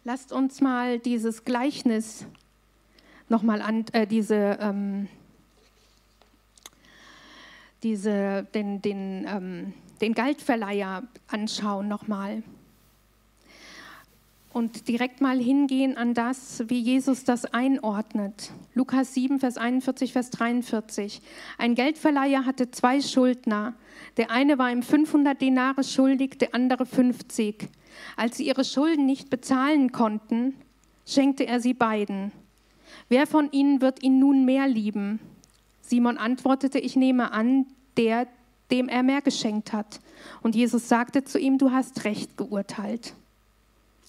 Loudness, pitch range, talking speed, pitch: -25 LUFS, 220-265 Hz, 120 wpm, 245 Hz